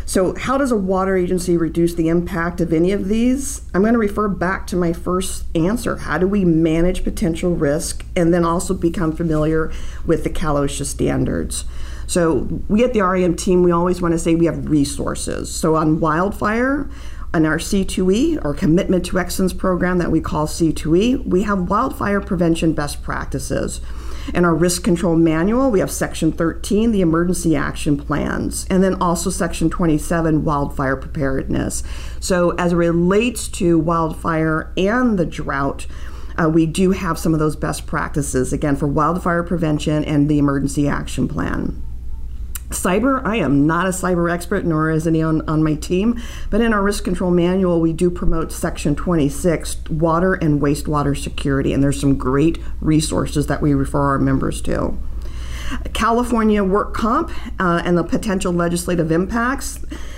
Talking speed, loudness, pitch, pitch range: 165 wpm, -18 LUFS, 170 Hz, 150-185 Hz